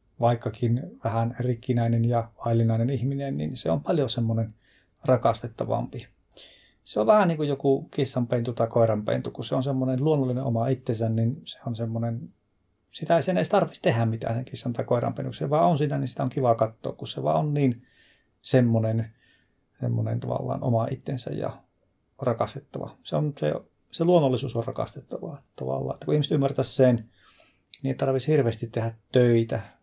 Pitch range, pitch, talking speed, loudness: 115-135 Hz, 120 Hz, 165 wpm, -26 LUFS